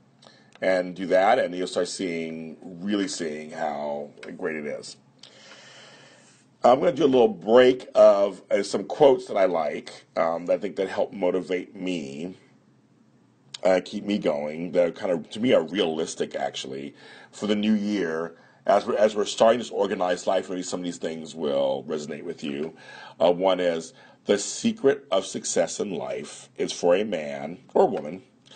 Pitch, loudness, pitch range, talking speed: 90 Hz, -24 LUFS, 80-105 Hz, 175 wpm